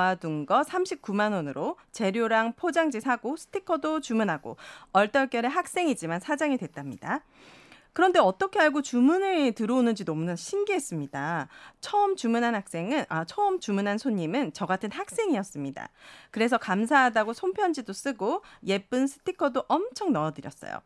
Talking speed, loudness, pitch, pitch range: 340 characters per minute, -27 LUFS, 235 Hz, 195-310 Hz